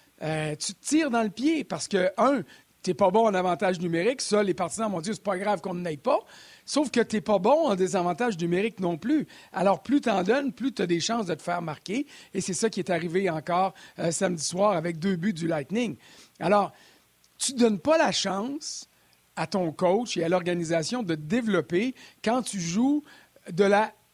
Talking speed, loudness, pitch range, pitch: 225 wpm, -26 LUFS, 175-235 Hz, 195 Hz